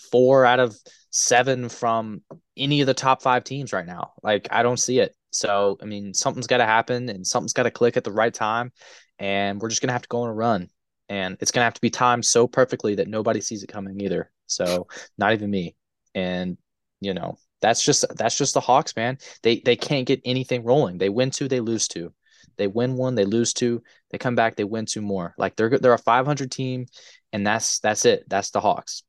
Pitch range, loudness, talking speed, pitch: 105-125 Hz, -22 LUFS, 230 wpm, 120 Hz